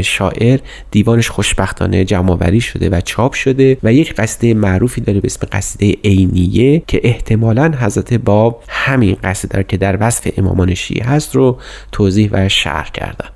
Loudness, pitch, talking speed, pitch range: -13 LUFS, 105 Hz, 155 wpm, 95-120 Hz